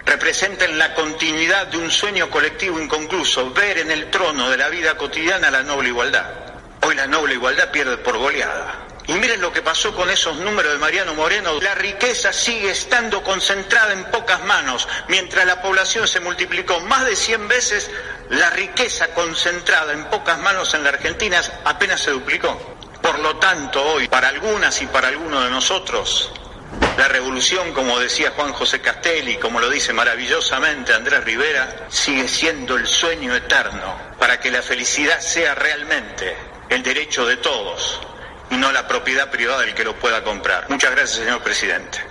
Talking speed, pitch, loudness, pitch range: 170 wpm, 185 Hz, -17 LUFS, 160-215 Hz